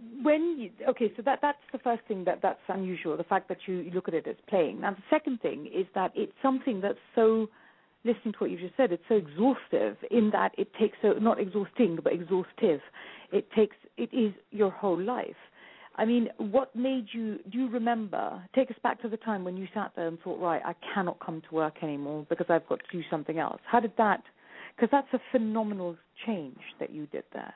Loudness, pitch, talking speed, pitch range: -30 LUFS, 215 Hz, 225 wpm, 185-240 Hz